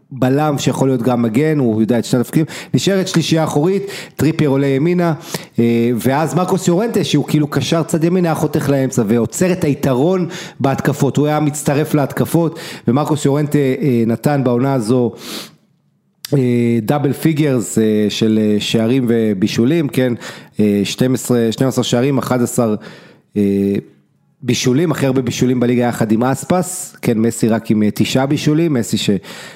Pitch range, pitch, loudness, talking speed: 120-155 Hz, 135 Hz, -15 LUFS, 140 wpm